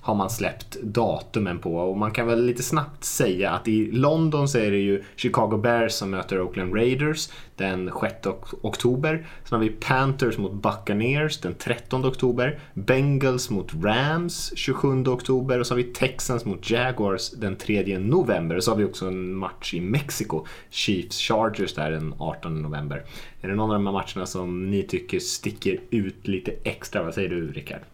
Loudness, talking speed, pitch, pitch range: -25 LUFS, 185 wpm, 110 Hz, 95-130 Hz